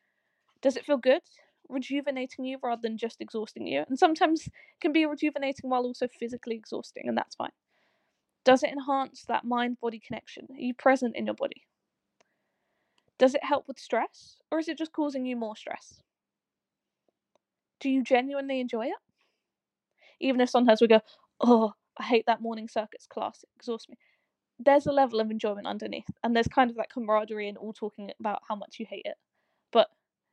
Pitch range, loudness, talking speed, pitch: 230-280 Hz, -28 LUFS, 180 wpm, 255 Hz